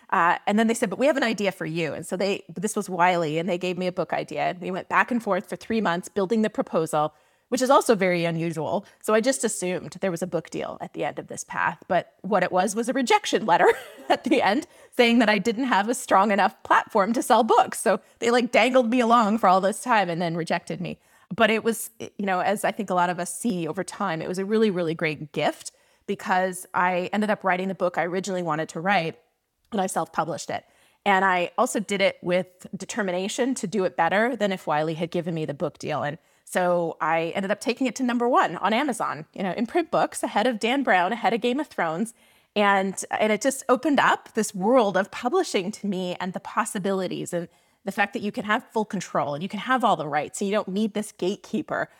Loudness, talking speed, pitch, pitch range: -24 LUFS, 250 wpm, 195 Hz, 180-230 Hz